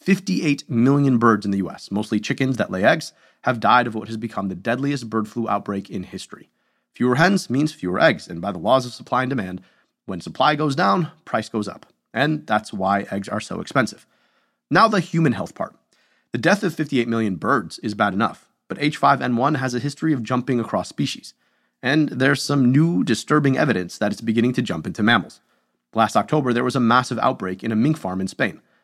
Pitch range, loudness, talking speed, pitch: 110-145 Hz, -21 LUFS, 210 wpm, 125 Hz